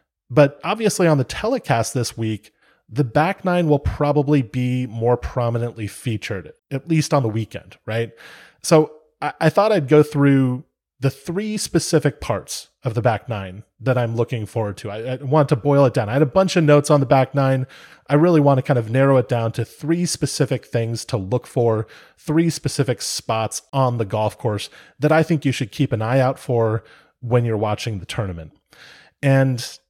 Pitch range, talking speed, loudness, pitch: 115-150 Hz, 195 wpm, -20 LUFS, 130 Hz